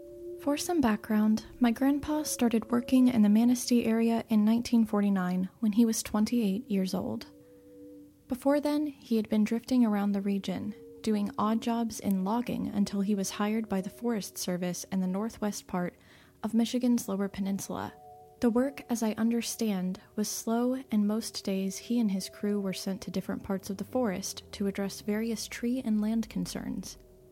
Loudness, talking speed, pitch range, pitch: -30 LUFS, 170 wpm, 195-240 Hz, 215 Hz